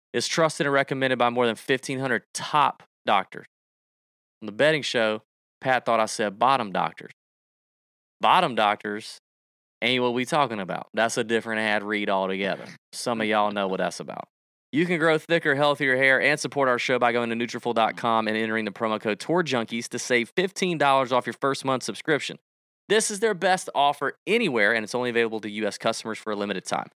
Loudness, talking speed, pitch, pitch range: -24 LUFS, 190 wpm, 120 Hz, 110-140 Hz